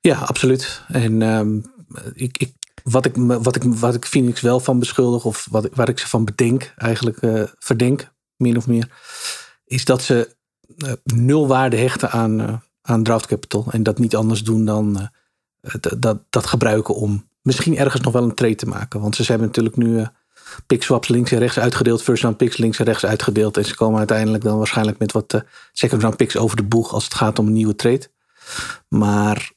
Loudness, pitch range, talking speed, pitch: -18 LUFS, 110-125 Hz, 215 wpm, 115 Hz